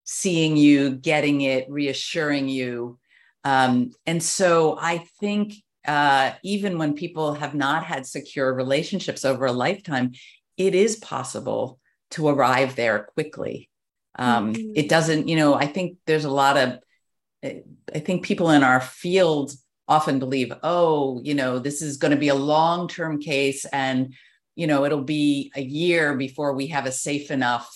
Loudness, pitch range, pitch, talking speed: -22 LUFS, 135-160 Hz, 145 Hz, 160 wpm